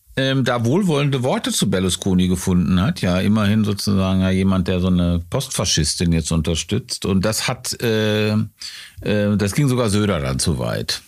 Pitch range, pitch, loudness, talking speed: 90-120 Hz, 100 Hz, -19 LUFS, 170 wpm